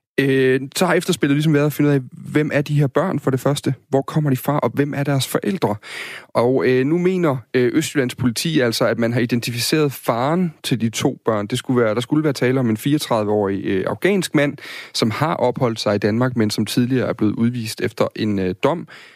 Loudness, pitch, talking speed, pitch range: -19 LUFS, 135 Hz, 230 wpm, 120-150 Hz